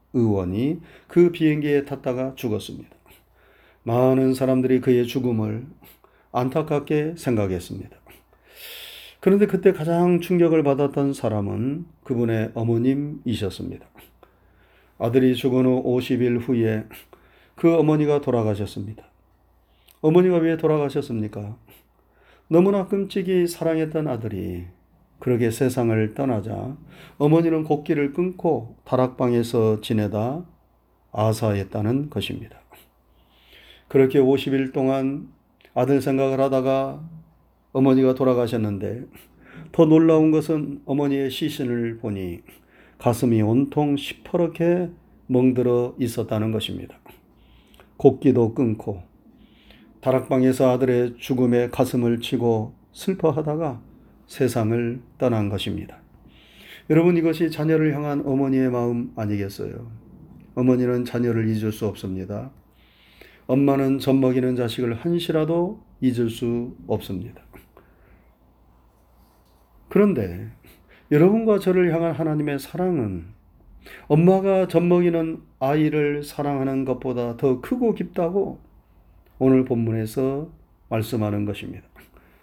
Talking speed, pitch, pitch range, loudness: 255 characters per minute, 130 Hz, 110-150 Hz, -22 LUFS